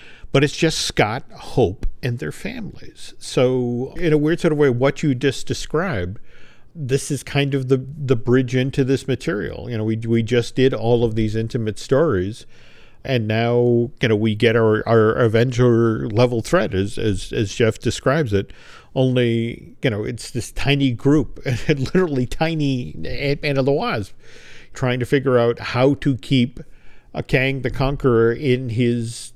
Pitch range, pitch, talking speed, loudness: 115-140 Hz, 125 Hz, 170 wpm, -20 LUFS